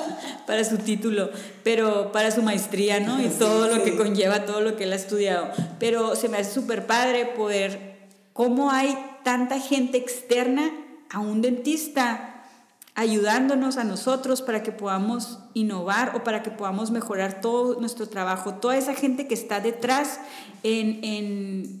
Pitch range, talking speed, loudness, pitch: 205-250 Hz, 155 wpm, -24 LUFS, 225 Hz